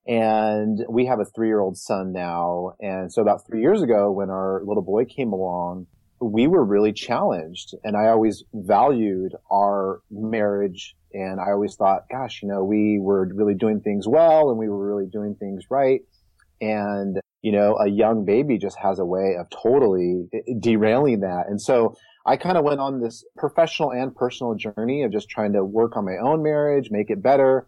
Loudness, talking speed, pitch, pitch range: -22 LUFS, 195 wpm, 105 Hz, 95-115 Hz